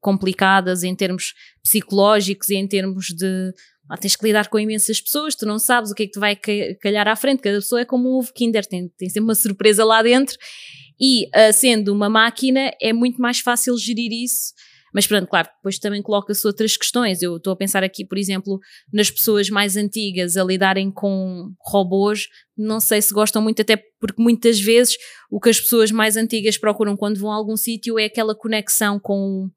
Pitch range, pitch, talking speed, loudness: 195-225 Hz, 210 Hz, 205 wpm, -18 LUFS